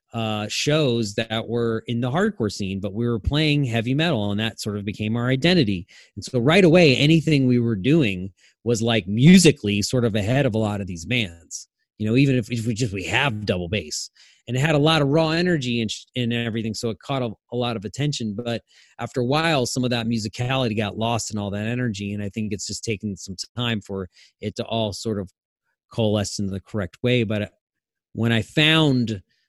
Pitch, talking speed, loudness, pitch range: 115 Hz, 220 wpm, -22 LUFS, 105-130 Hz